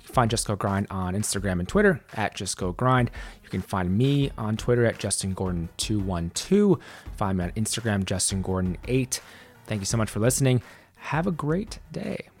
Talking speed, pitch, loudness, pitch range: 180 wpm, 105 Hz, -26 LUFS, 95-120 Hz